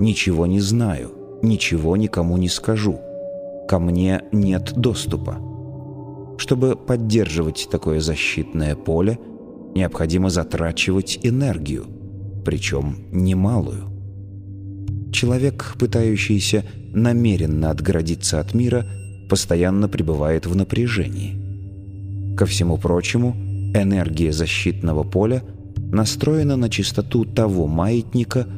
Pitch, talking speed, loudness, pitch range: 100 Hz, 90 wpm, -20 LUFS, 90-115 Hz